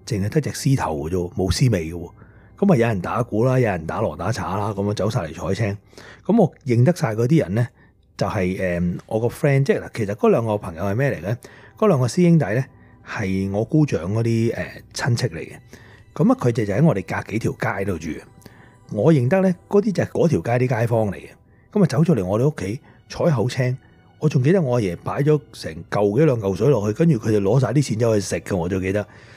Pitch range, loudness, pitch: 100-140 Hz, -21 LUFS, 115 Hz